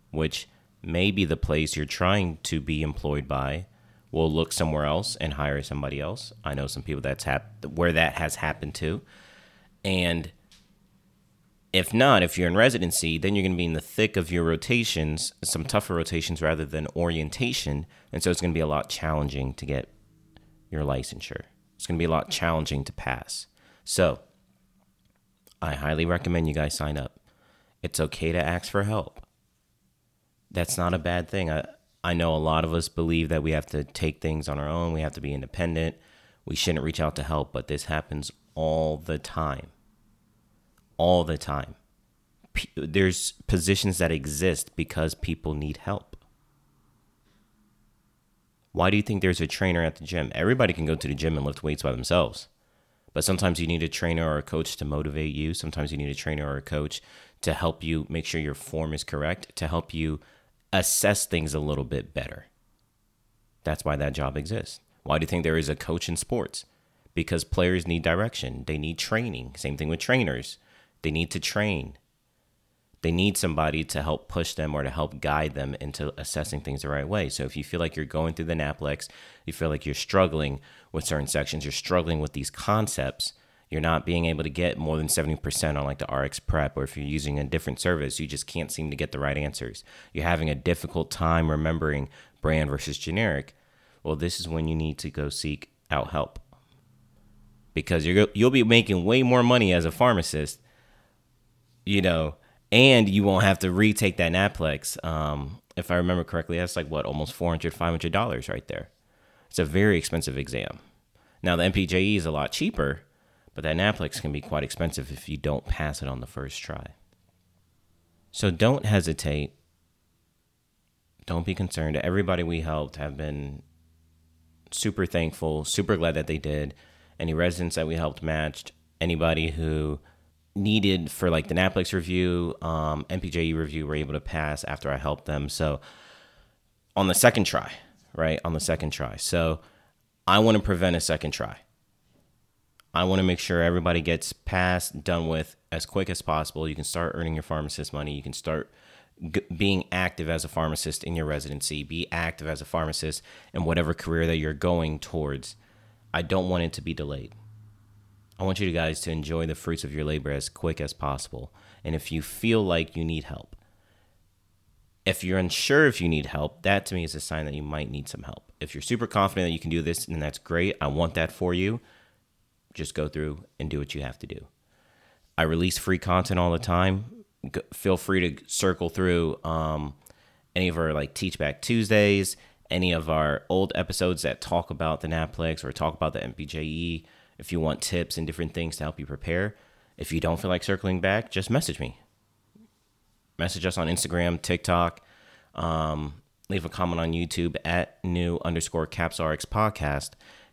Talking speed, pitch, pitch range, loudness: 190 wpm, 80 Hz, 75-90 Hz, -27 LUFS